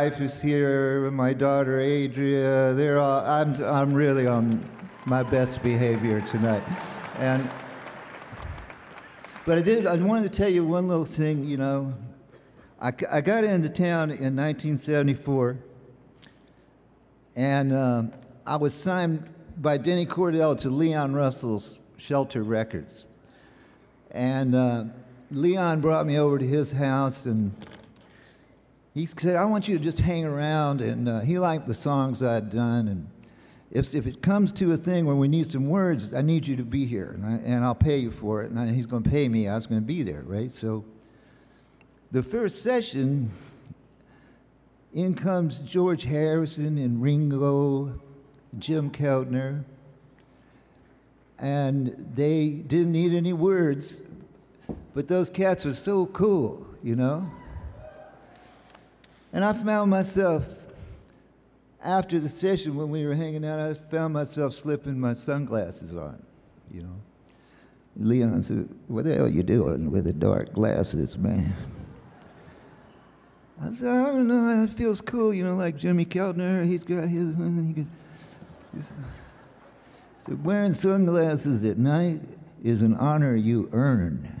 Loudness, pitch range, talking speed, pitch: -25 LUFS, 125-165 Hz, 150 wpm, 140 Hz